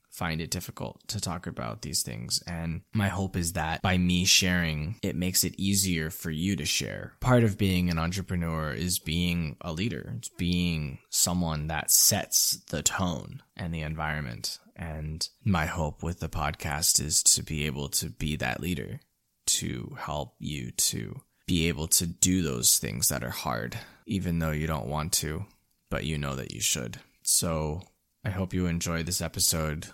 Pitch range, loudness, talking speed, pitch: 80-90 Hz, -27 LUFS, 180 wpm, 85 Hz